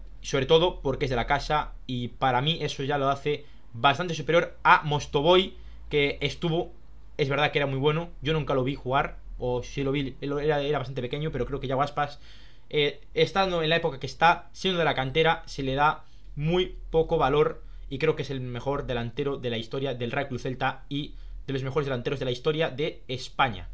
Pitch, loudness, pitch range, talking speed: 140 Hz, -27 LUFS, 130-155 Hz, 210 wpm